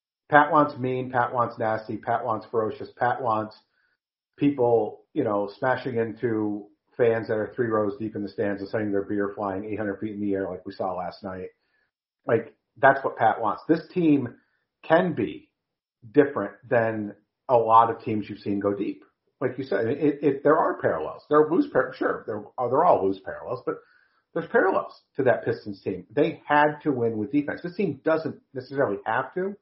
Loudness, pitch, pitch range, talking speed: -25 LUFS, 115 Hz, 105-145 Hz, 195 wpm